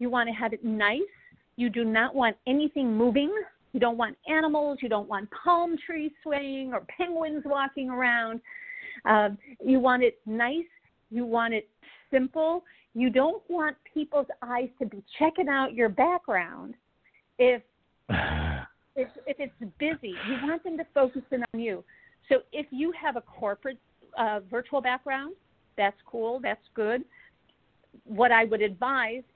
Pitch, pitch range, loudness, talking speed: 260 Hz, 235-310 Hz, -28 LUFS, 155 wpm